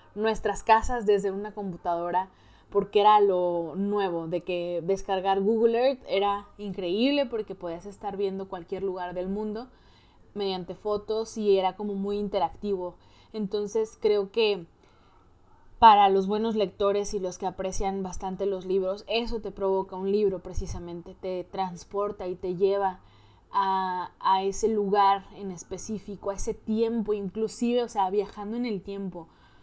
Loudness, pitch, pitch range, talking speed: -27 LUFS, 200 Hz, 185-210 Hz, 145 wpm